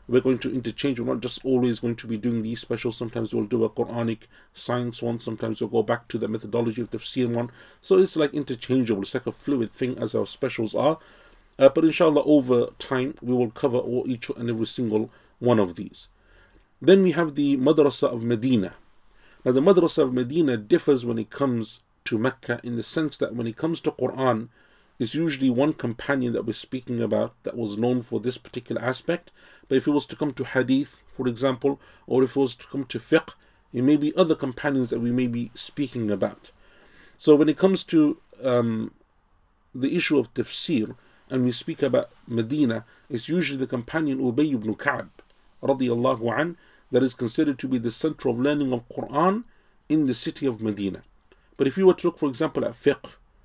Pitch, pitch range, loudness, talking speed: 125 Hz, 115-145 Hz, -24 LUFS, 205 wpm